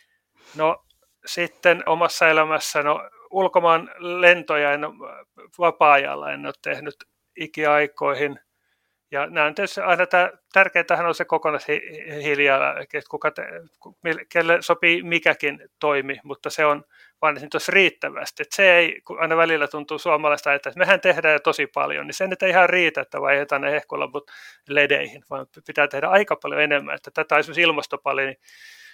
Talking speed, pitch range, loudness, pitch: 150 wpm, 145-175 Hz, -20 LUFS, 160 Hz